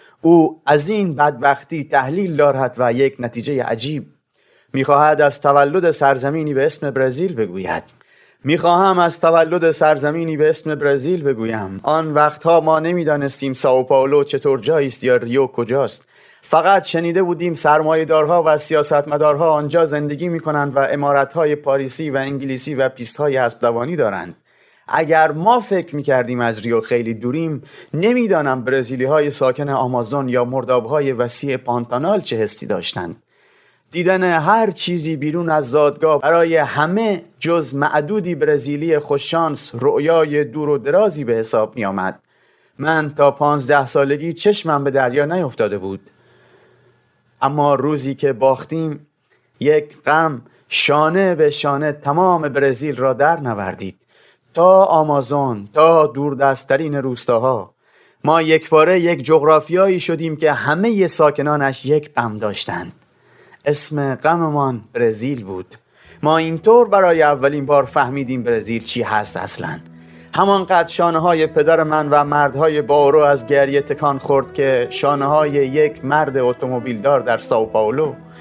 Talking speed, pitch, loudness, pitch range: 135 wpm, 145 Hz, -16 LUFS, 135-160 Hz